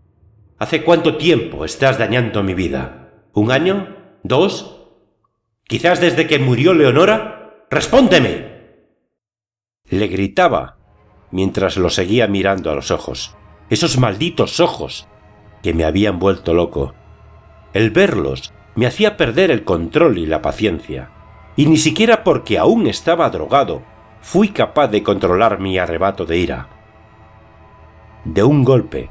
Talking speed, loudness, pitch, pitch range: 125 wpm, -15 LUFS, 105 Hz, 95-130 Hz